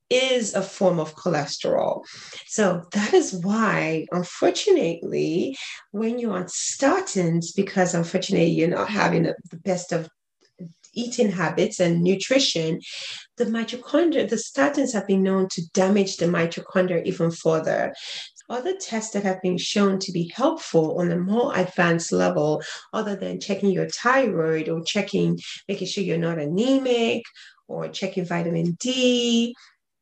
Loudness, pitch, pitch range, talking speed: -23 LUFS, 190 Hz, 170-230 Hz, 140 wpm